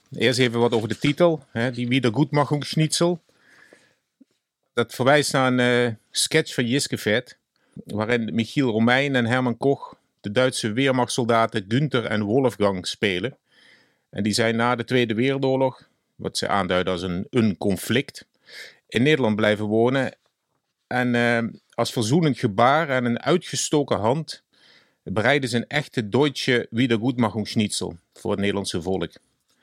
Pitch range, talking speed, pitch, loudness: 110-135 Hz, 135 wpm, 120 Hz, -22 LUFS